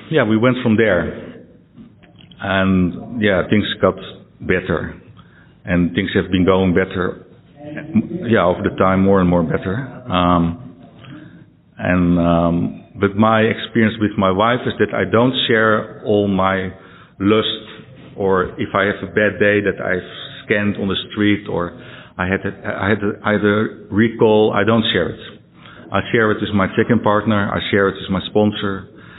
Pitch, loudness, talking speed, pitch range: 100 Hz, -17 LUFS, 165 wpm, 95-110 Hz